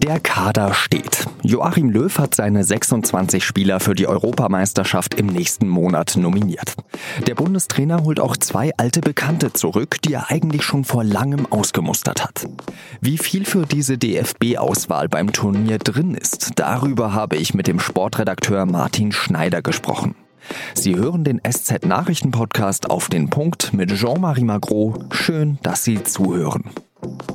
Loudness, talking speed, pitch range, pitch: -18 LUFS, 140 wpm, 100-150 Hz, 120 Hz